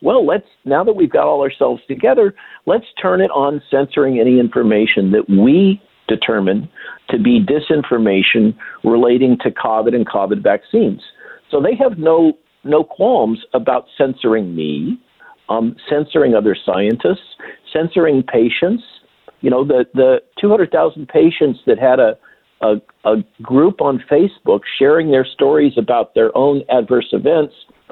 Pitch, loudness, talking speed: 140 Hz, -14 LUFS, 145 wpm